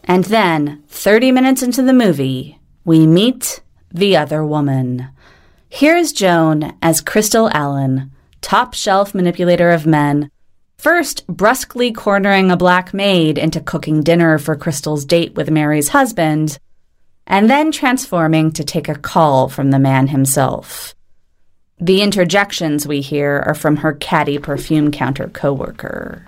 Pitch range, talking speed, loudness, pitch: 145-195 Hz, 135 wpm, -14 LUFS, 160 Hz